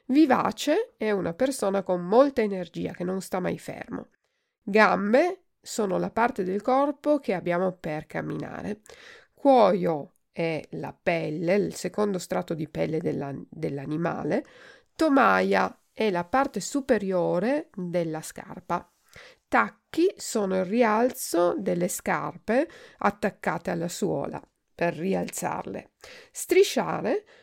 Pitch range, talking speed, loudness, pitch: 175-270 Hz, 115 wpm, -26 LUFS, 205 Hz